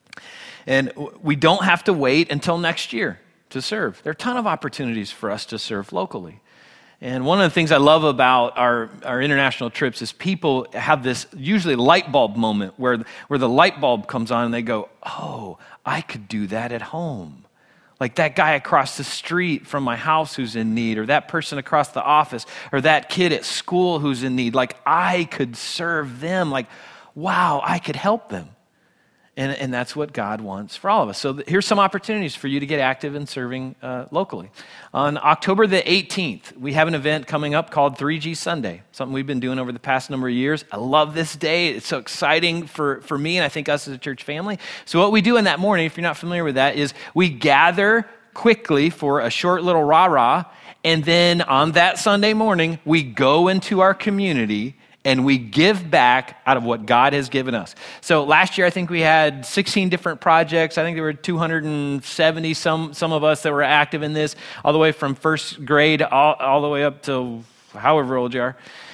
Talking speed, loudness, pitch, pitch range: 215 wpm, -19 LUFS, 150 Hz, 130-170 Hz